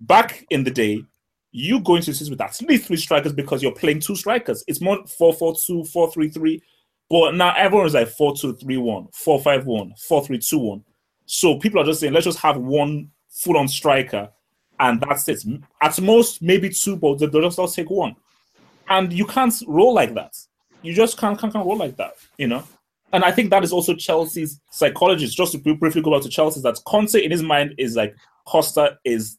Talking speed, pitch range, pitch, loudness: 215 wpm, 145-190 Hz, 160 Hz, -19 LUFS